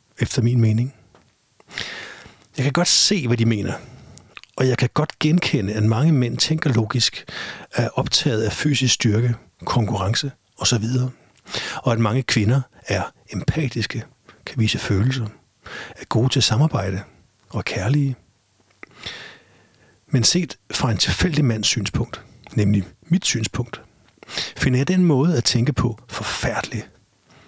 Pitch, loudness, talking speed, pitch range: 120 Hz, -20 LUFS, 135 wpm, 110-135 Hz